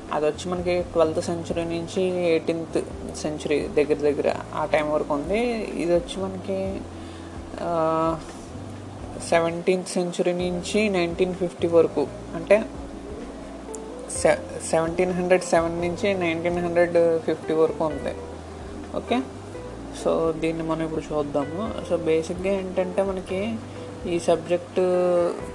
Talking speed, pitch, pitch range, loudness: 110 wpm, 170 Hz, 150-180 Hz, -24 LUFS